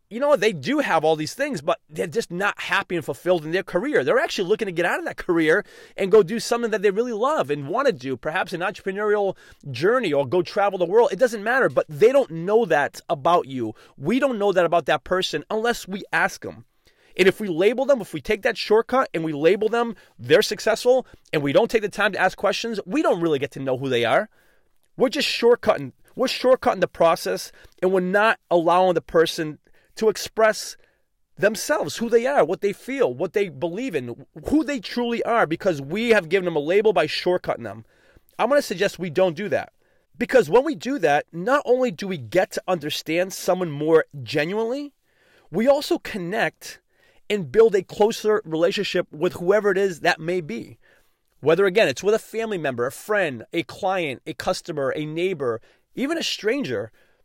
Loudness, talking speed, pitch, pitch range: -22 LUFS, 210 wpm, 195 Hz, 170-230 Hz